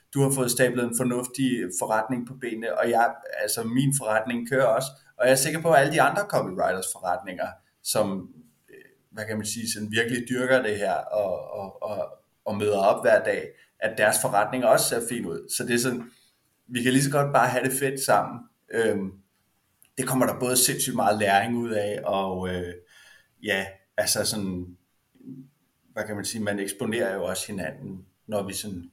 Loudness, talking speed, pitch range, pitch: -25 LUFS, 190 wpm, 100-130 Hz, 115 Hz